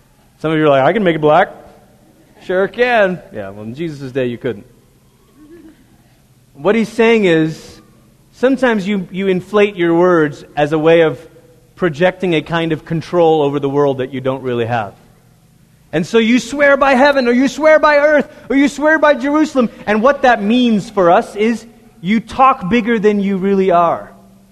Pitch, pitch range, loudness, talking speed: 190 Hz, 155-240 Hz, -14 LUFS, 185 wpm